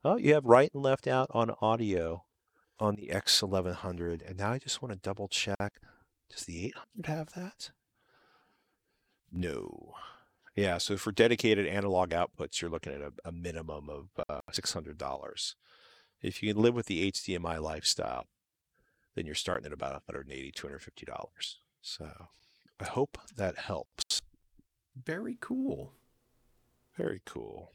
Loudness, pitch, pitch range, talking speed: -33 LUFS, 100 Hz, 90-125 Hz, 140 wpm